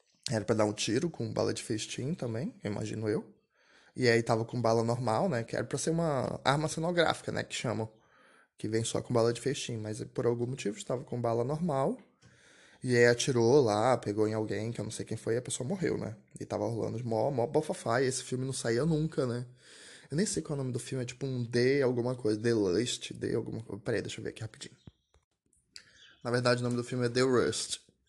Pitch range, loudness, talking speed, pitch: 110-135 Hz, -31 LUFS, 235 wpm, 120 Hz